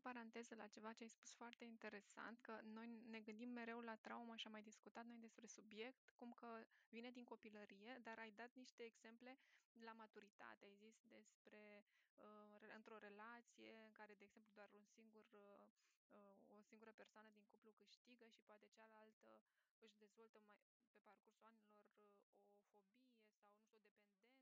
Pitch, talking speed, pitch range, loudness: 220 Hz, 165 wpm, 210-230 Hz, -61 LUFS